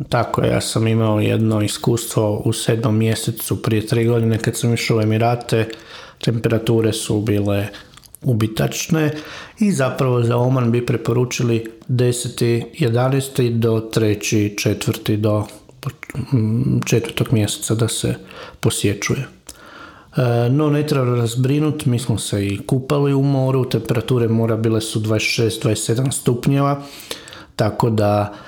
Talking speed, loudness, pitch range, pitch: 120 wpm, -19 LUFS, 110-130 Hz, 115 Hz